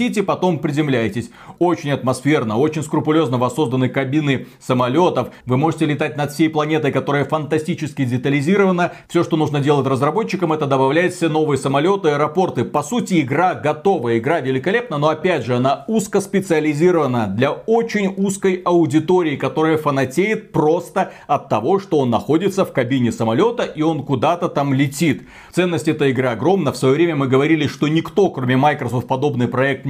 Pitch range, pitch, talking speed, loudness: 135-175 Hz, 155 Hz, 155 wpm, -18 LUFS